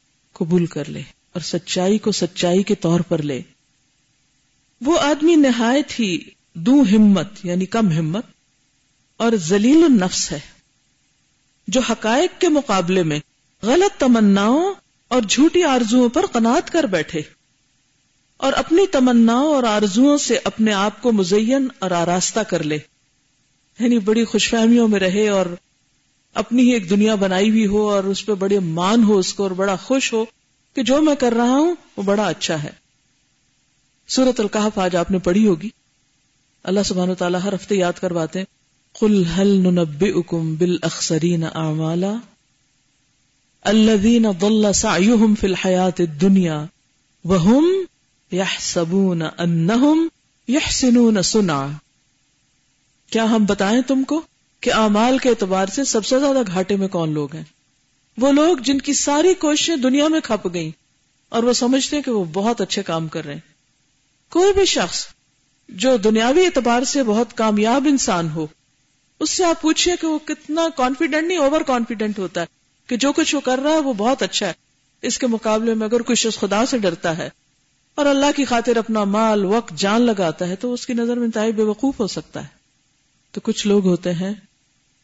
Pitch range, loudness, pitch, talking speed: 160-245 Hz, -18 LUFS, 200 Hz, 165 wpm